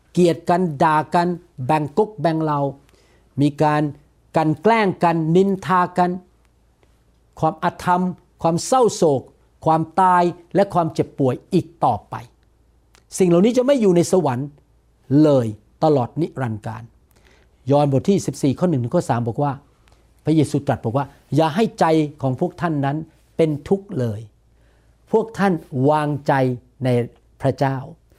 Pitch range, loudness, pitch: 130-175 Hz, -19 LUFS, 155 Hz